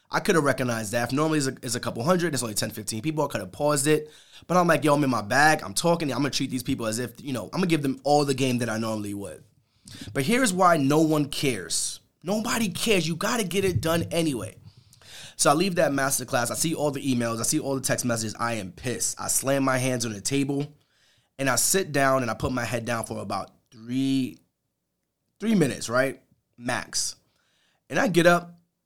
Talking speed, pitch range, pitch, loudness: 245 wpm, 120-160 Hz, 135 Hz, -25 LUFS